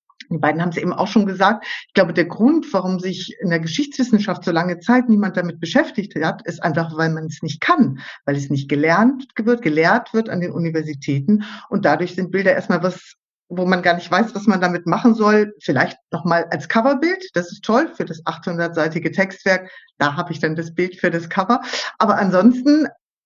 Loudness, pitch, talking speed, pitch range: -19 LUFS, 185 Hz, 205 wpm, 170-210 Hz